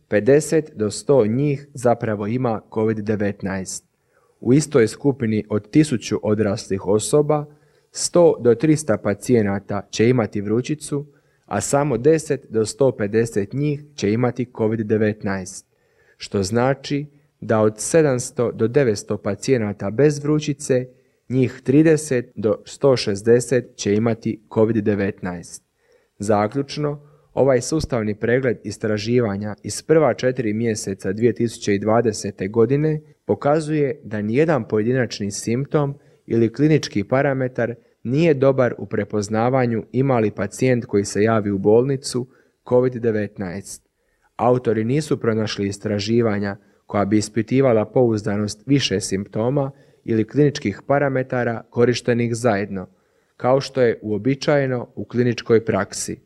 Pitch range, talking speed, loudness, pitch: 105-135 Hz, 105 wpm, -20 LUFS, 115 Hz